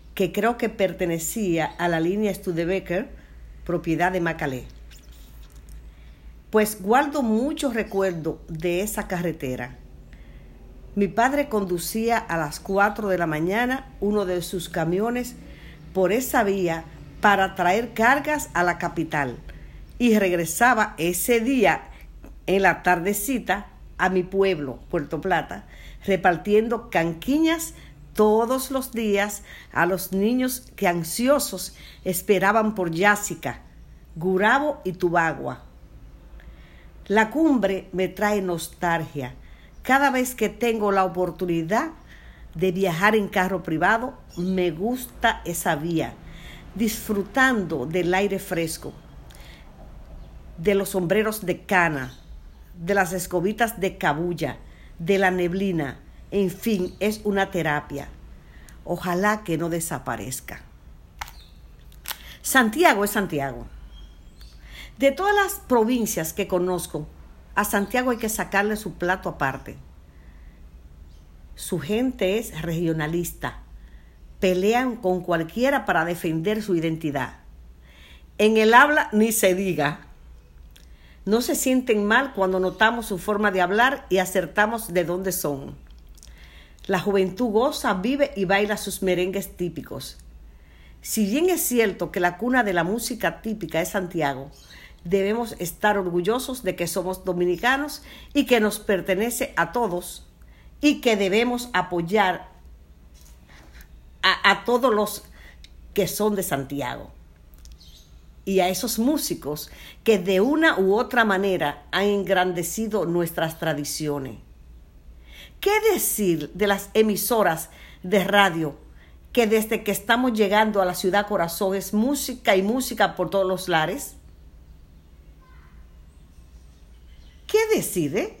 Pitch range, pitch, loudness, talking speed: 145-215 Hz, 185 Hz, -23 LUFS, 115 wpm